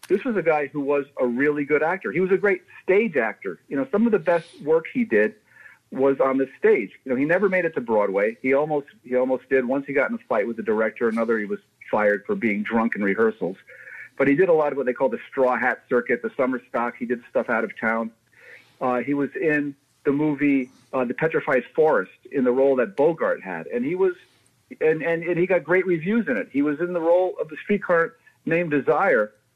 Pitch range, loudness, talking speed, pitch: 125-190 Hz, -23 LUFS, 245 wpm, 145 Hz